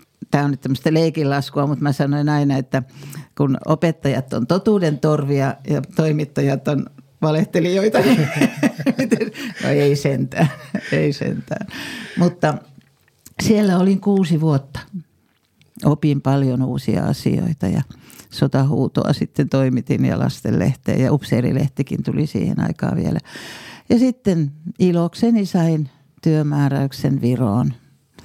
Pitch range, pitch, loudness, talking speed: 140-175 Hz, 150 Hz, -19 LUFS, 110 wpm